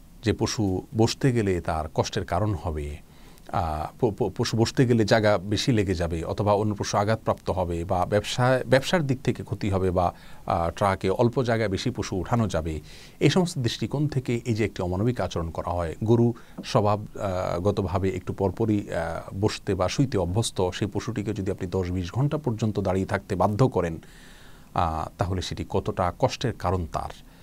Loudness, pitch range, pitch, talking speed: -26 LUFS, 90-115 Hz, 105 Hz, 160 wpm